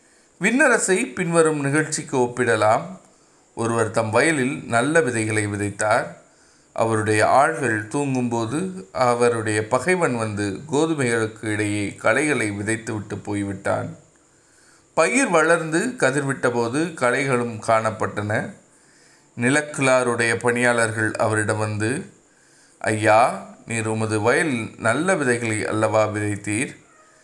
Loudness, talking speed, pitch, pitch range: -21 LUFS, 85 wpm, 115 Hz, 110-130 Hz